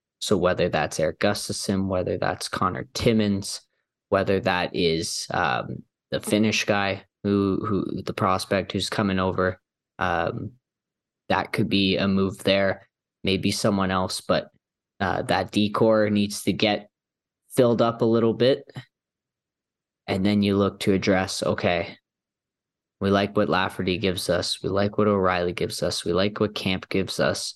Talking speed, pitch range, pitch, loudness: 150 wpm, 95-105 Hz, 100 Hz, -24 LUFS